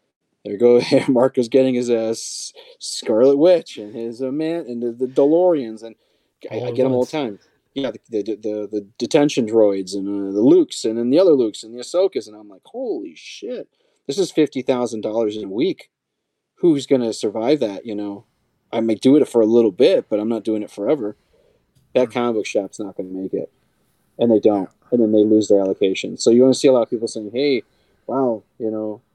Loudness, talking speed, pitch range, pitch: -19 LUFS, 220 wpm, 110-135 Hz, 120 Hz